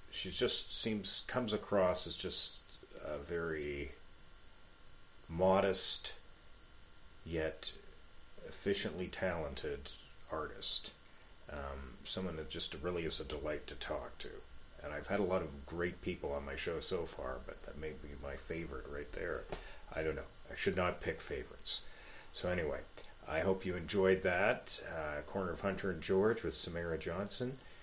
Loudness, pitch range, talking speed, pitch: -38 LUFS, 75-95 Hz, 150 wpm, 80 Hz